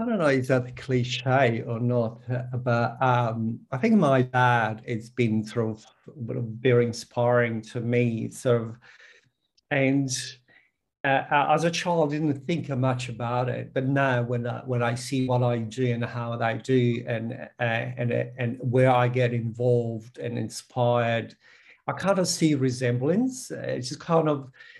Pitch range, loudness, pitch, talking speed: 120-135 Hz, -25 LUFS, 125 Hz, 165 wpm